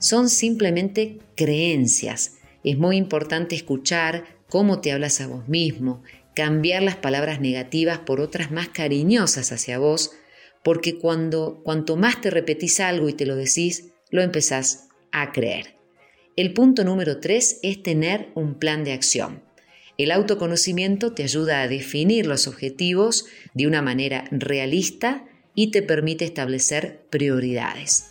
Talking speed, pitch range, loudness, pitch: 140 wpm, 140-185 Hz, -22 LUFS, 160 Hz